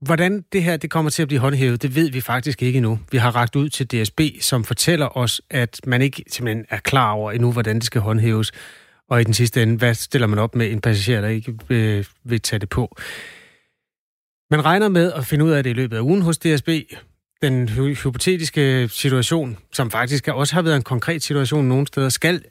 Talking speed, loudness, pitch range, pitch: 220 wpm, -19 LUFS, 120-155 Hz, 130 Hz